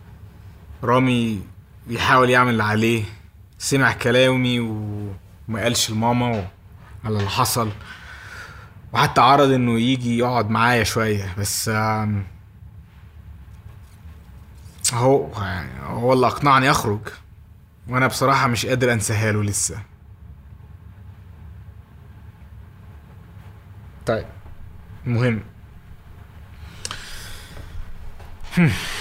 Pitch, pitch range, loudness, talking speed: 100 Hz, 95-115 Hz, -20 LUFS, 70 wpm